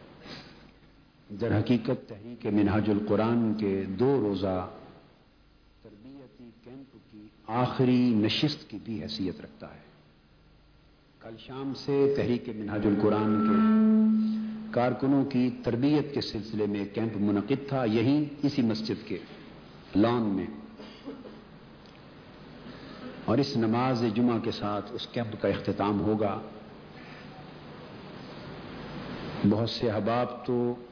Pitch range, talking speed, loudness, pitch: 105-130 Hz, 105 wpm, -28 LUFS, 115 Hz